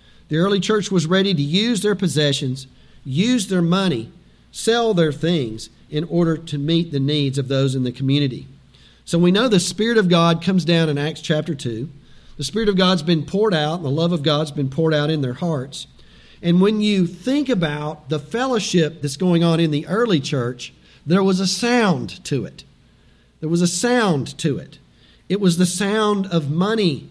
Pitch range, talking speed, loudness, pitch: 145-190 Hz, 195 wpm, -19 LUFS, 165 Hz